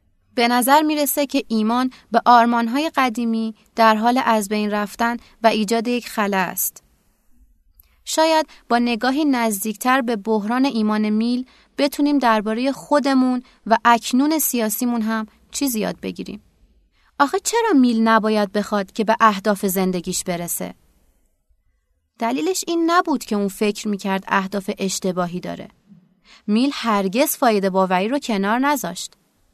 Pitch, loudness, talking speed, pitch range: 230 Hz, -19 LUFS, 130 wpm, 210-260 Hz